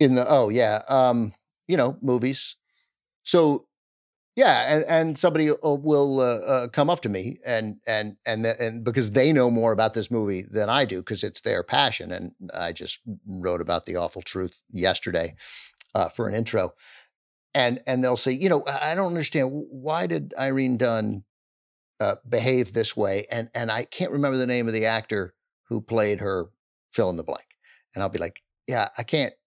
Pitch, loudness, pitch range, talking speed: 120 Hz, -24 LUFS, 110-135 Hz, 190 wpm